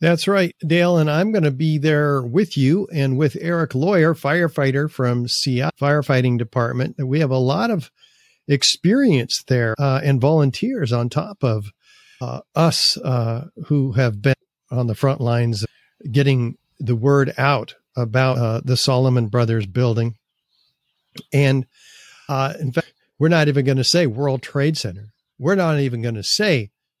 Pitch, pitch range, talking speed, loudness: 140 Hz, 125-155 Hz, 160 wpm, -19 LUFS